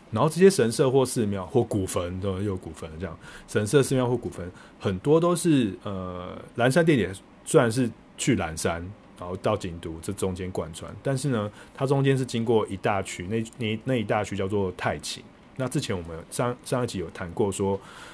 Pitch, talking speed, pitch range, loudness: 105 Hz, 280 characters per minute, 95-130 Hz, -26 LUFS